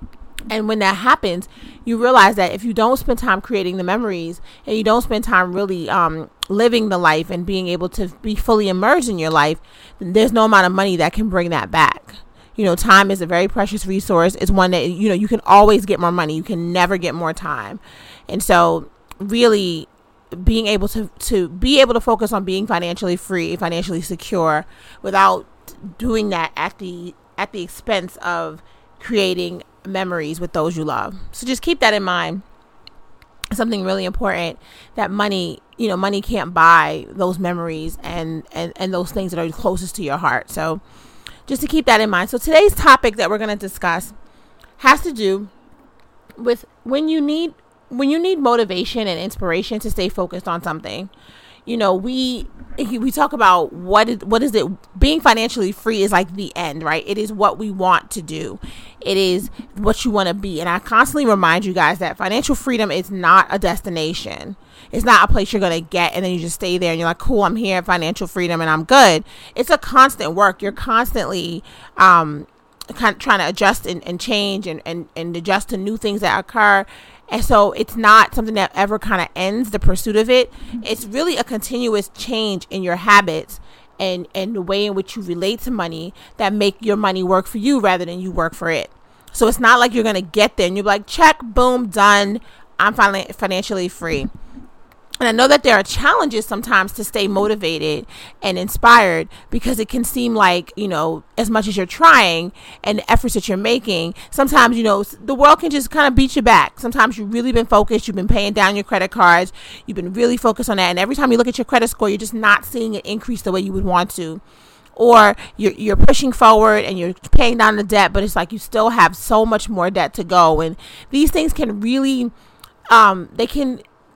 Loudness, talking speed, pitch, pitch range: -16 LUFS, 210 wpm, 200 Hz, 180-230 Hz